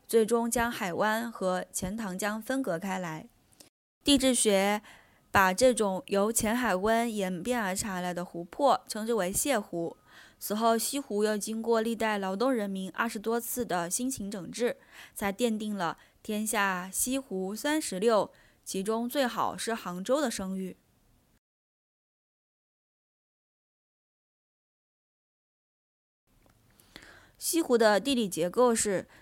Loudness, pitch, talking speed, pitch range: -29 LUFS, 215 Hz, 180 characters per minute, 190-235 Hz